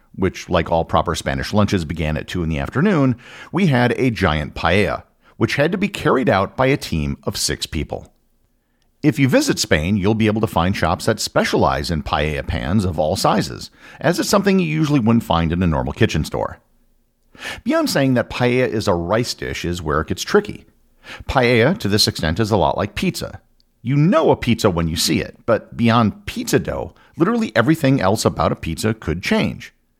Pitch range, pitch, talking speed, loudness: 85-125 Hz, 110 Hz, 200 wpm, -18 LUFS